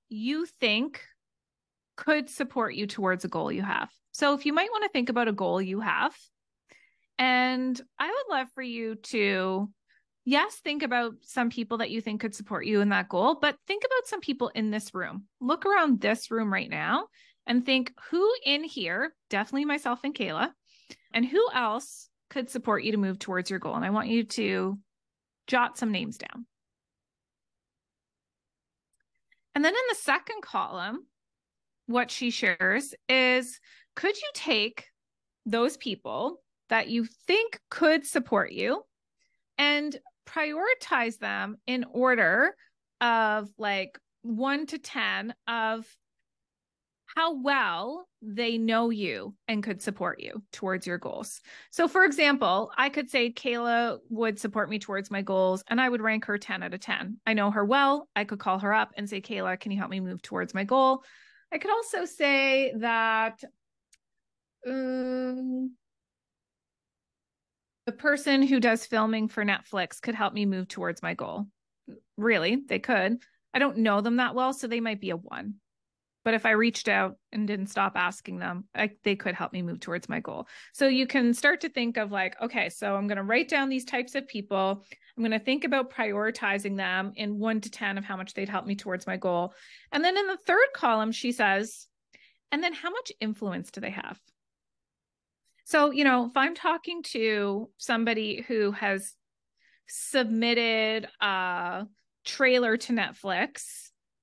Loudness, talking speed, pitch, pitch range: -28 LUFS, 170 wpm, 235 Hz, 205-275 Hz